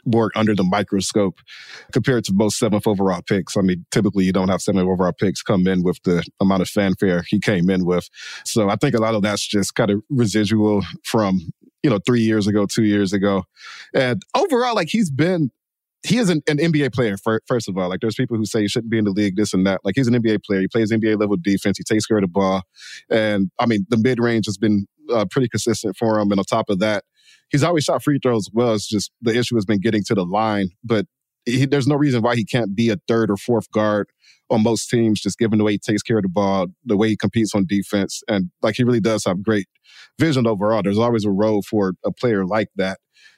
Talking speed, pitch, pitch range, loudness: 250 wpm, 110 Hz, 100-115 Hz, -19 LUFS